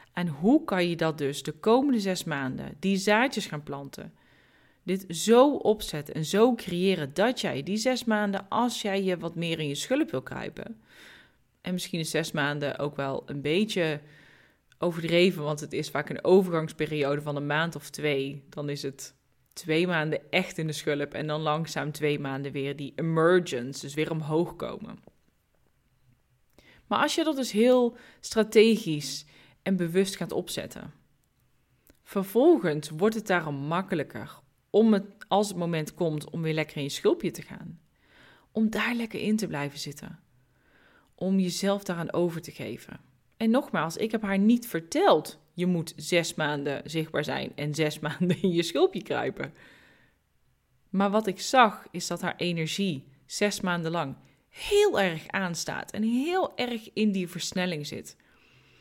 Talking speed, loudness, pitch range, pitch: 165 wpm, -27 LUFS, 150-205 Hz, 175 Hz